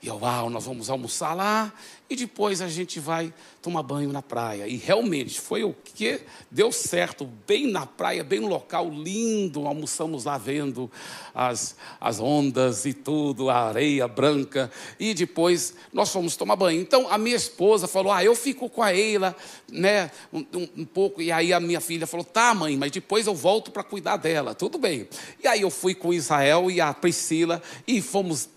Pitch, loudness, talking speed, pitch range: 170 Hz, -25 LUFS, 185 wpm, 145-200 Hz